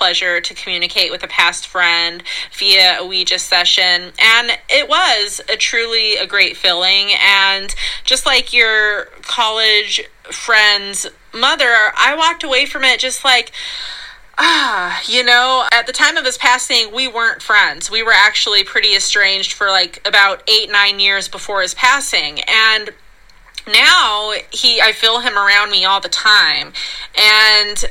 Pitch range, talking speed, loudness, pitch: 195-245 Hz, 155 wpm, -11 LUFS, 215 Hz